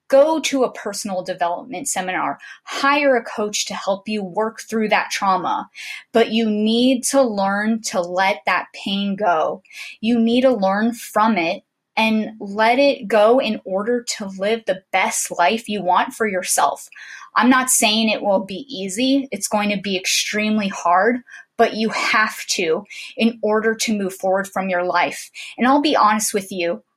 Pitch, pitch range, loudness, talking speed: 215 Hz, 195-235 Hz, -19 LUFS, 175 wpm